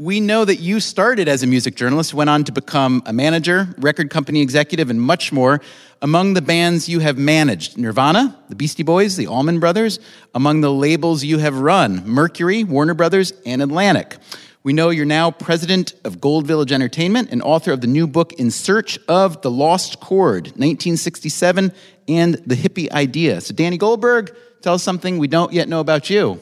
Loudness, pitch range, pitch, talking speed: -16 LUFS, 145-185 Hz, 165 Hz, 190 wpm